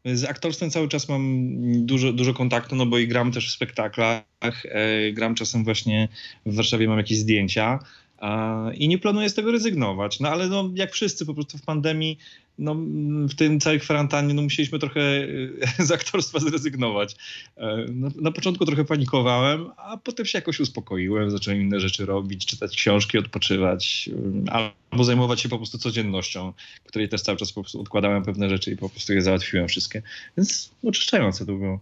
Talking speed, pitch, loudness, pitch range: 170 wpm, 120 Hz, -23 LUFS, 105-150 Hz